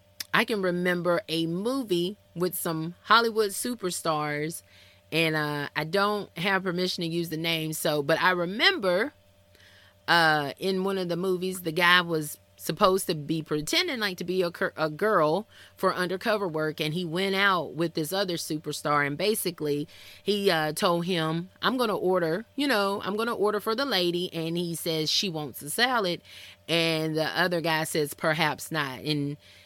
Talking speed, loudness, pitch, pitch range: 170 wpm, -26 LUFS, 170 Hz, 155-190 Hz